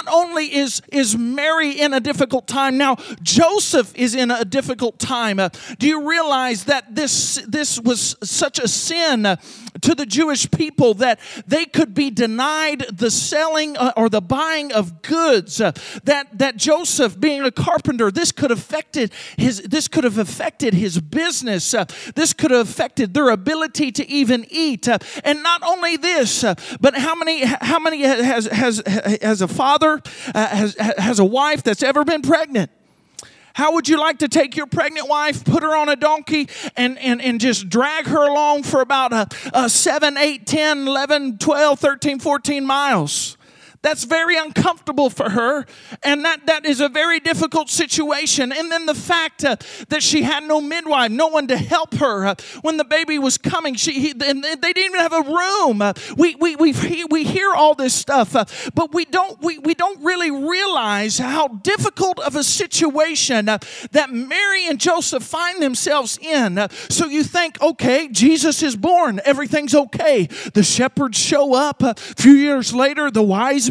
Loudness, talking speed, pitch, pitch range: -17 LUFS, 175 wpm, 285 Hz, 245-315 Hz